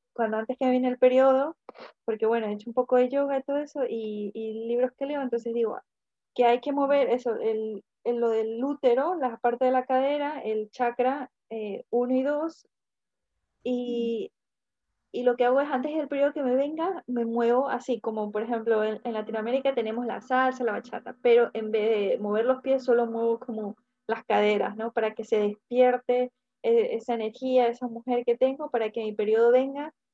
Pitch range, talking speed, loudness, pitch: 225-260 Hz, 195 wpm, -27 LUFS, 245 Hz